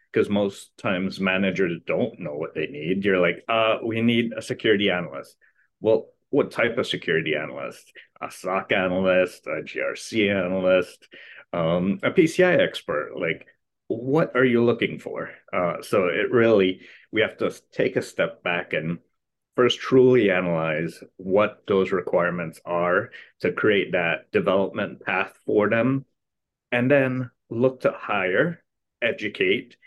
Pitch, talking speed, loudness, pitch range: 110 Hz, 145 wpm, -23 LUFS, 95-125 Hz